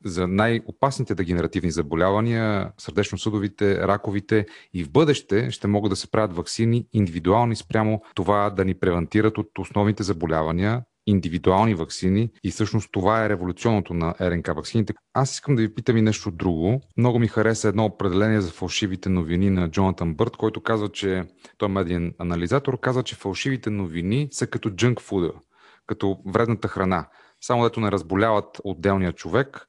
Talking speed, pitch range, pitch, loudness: 160 wpm, 95-110 Hz, 105 Hz, -23 LUFS